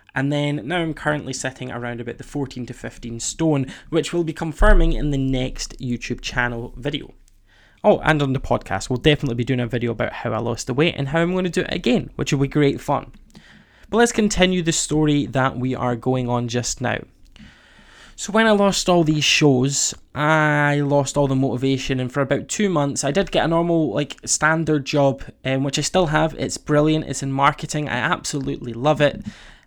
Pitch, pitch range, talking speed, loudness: 145 Hz, 125-155 Hz, 210 wpm, -20 LUFS